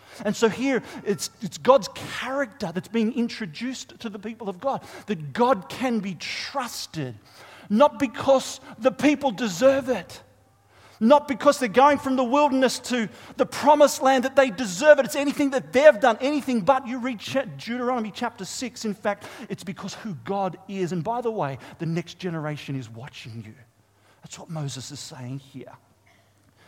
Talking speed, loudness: 170 wpm, -23 LUFS